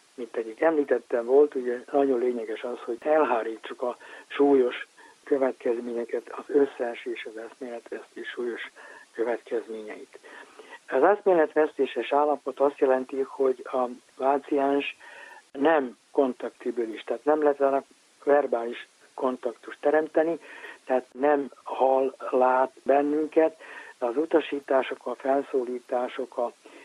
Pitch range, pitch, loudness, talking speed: 130-160 Hz, 140 Hz, -26 LUFS, 110 wpm